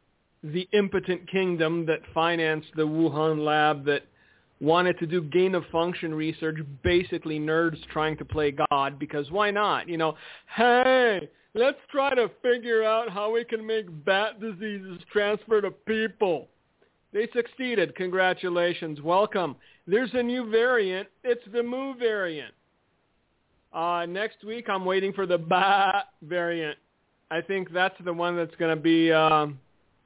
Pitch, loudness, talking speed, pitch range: 180 Hz, -26 LUFS, 140 wpm, 160-210 Hz